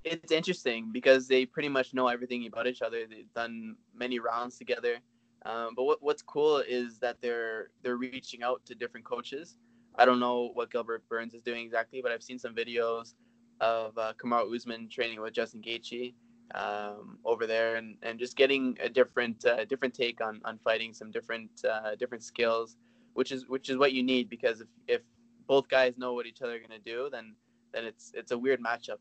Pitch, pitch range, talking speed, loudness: 120 Hz, 115-130 Hz, 205 wpm, -32 LUFS